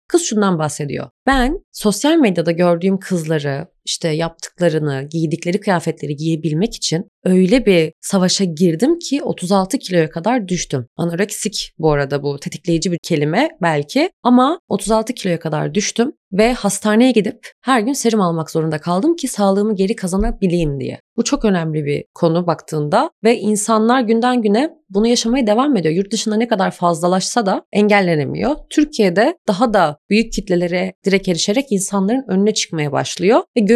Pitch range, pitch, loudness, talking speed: 170-230 Hz, 200 Hz, -17 LUFS, 150 wpm